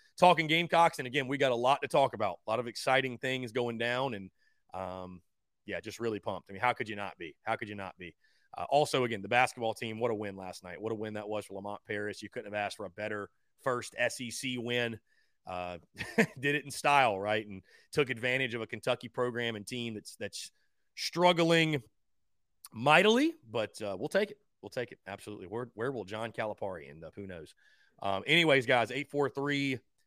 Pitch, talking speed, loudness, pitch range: 120 Hz, 215 wpm, -32 LUFS, 100-135 Hz